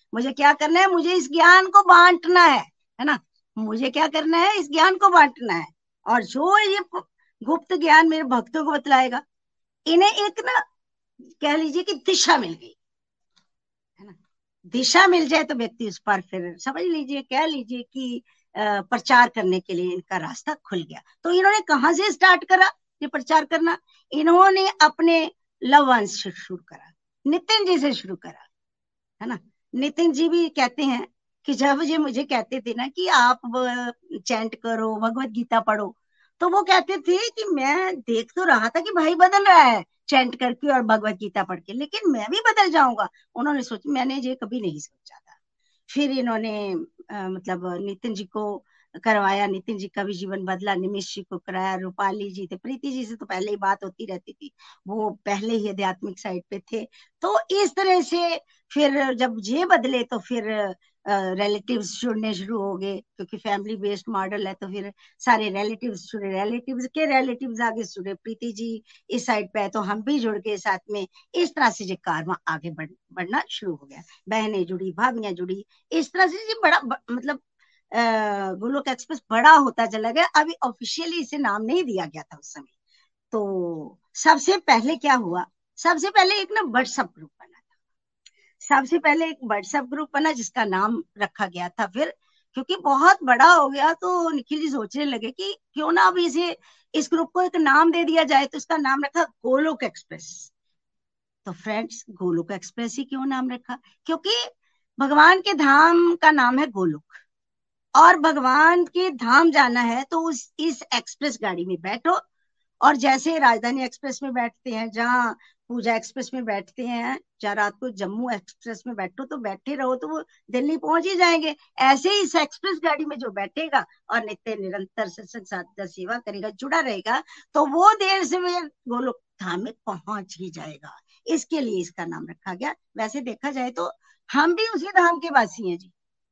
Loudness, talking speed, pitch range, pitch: -21 LUFS, 180 wpm, 210-325 Hz, 255 Hz